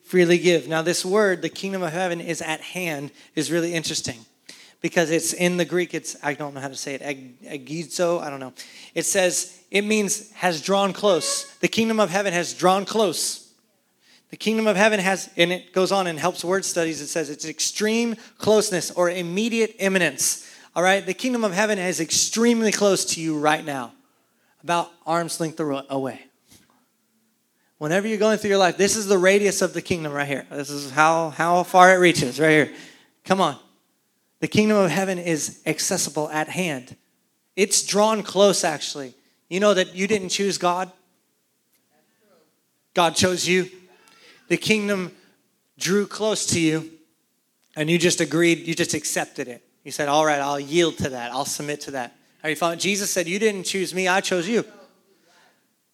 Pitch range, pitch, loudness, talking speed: 160-200 Hz, 180 Hz, -22 LUFS, 180 wpm